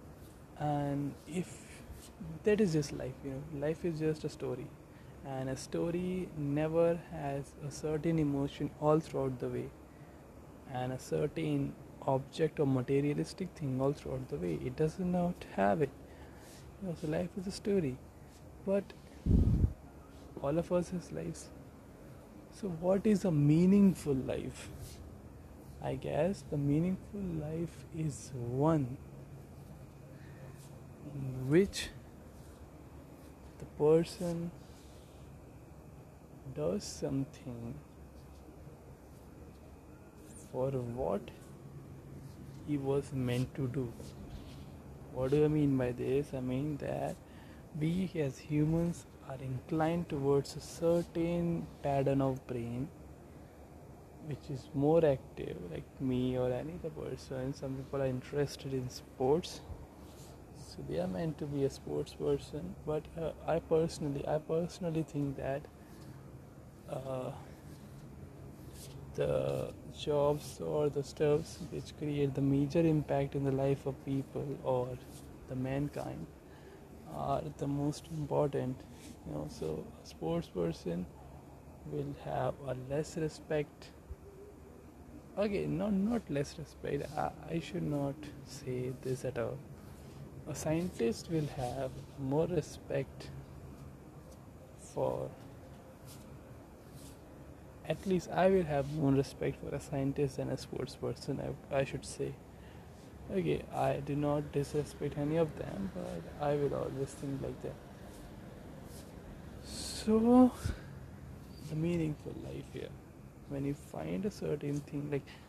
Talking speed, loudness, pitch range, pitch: 120 wpm, -35 LUFS, 125-155 Hz, 140 Hz